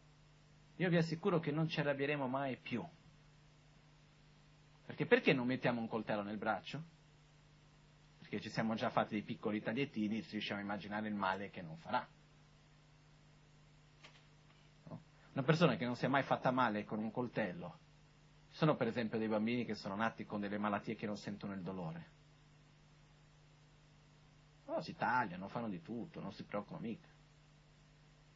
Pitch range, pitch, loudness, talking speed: 125-150 Hz, 150 Hz, -39 LUFS, 155 wpm